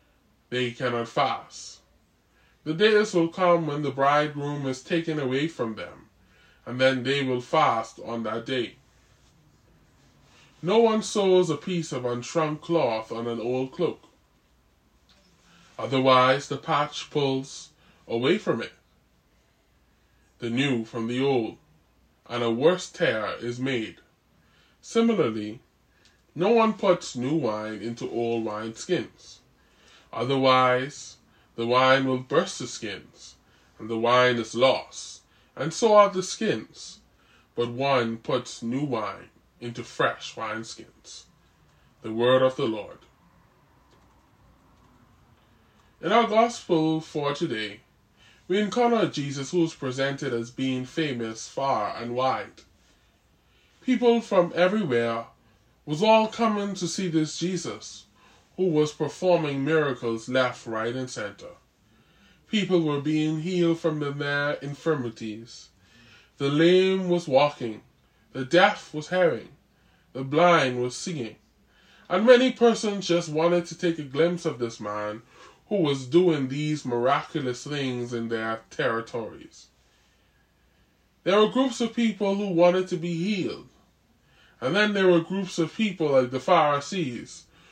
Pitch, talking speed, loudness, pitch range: 140 Hz, 130 wpm, -25 LUFS, 120-170 Hz